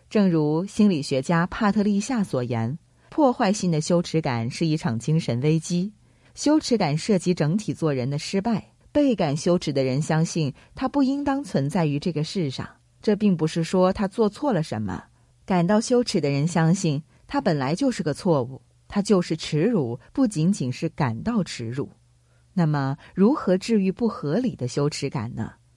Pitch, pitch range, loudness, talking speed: 165 Hz, 140-205 Hz, -24 LUFS, 260 characters per minute